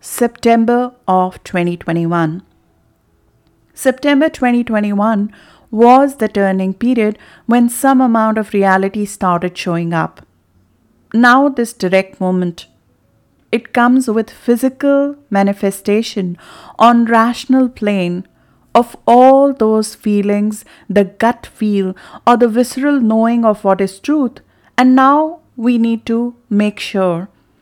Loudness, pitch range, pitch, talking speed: -14 LUFS, 190-240 Hz, 220 Hz, 110 wpm